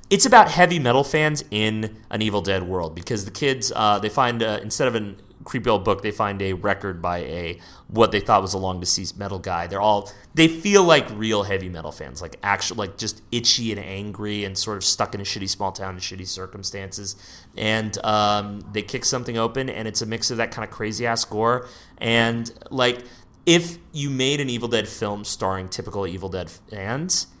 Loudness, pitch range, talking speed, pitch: -22 LUFS, 95-115 Hz, 210 wpm, 105 Hz